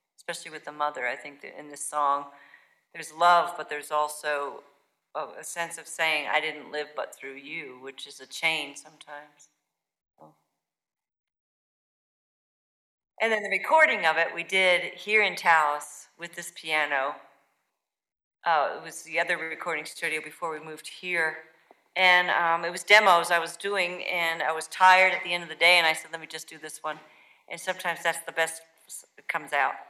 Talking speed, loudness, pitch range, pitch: 180 wpm, -25 LUFS, 150-175 Hz, 160 Hz